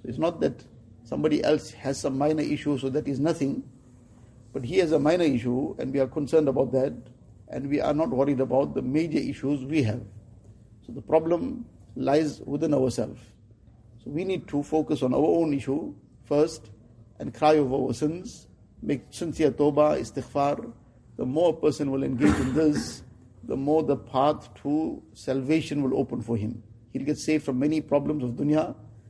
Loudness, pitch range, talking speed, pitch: -26 LUFS, 120-150 Hz, 180 wpm, 135 Hz